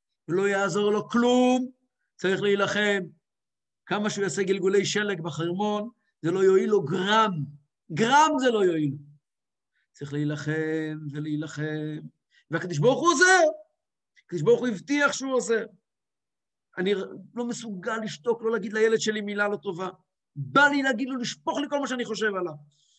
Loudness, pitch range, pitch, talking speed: -25 LUFS, 170-235 Hz, 200 Hz, 145 wpm